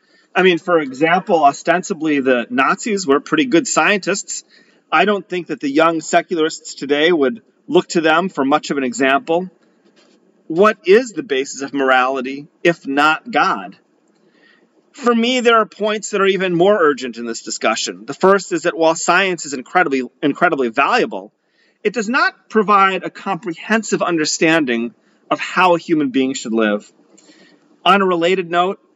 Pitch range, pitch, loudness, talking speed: 145-195 Hz, 170 Hz, -16 LUFS, 160 wpm